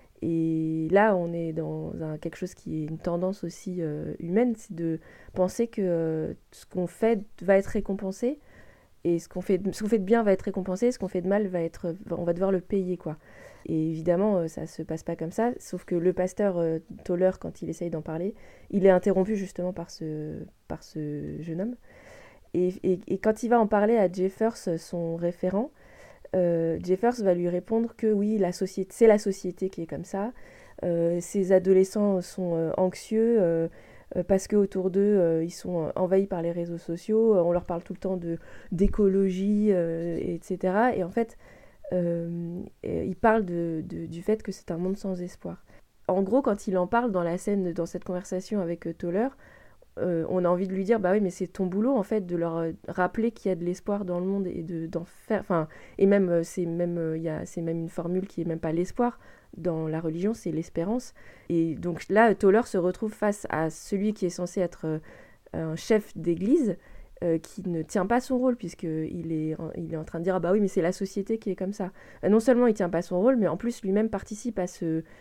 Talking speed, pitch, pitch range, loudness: 220 wpm, 185 Hz, 170-205 Hz, -27 LUFS